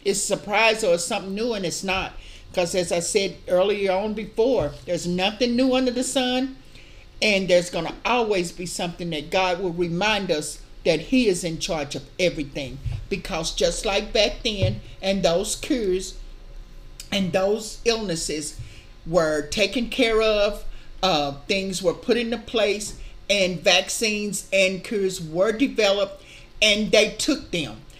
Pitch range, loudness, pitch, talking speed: 175-215 Hz, -23 LUFS, 195 Hz, 155 wpm